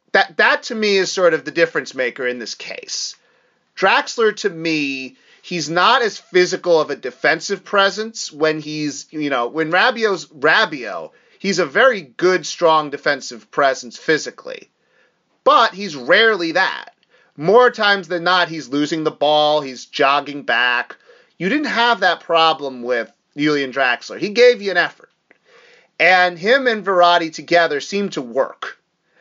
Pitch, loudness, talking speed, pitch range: 175 Hz, -17 LUFS, 155 wpm, 150-200 Hz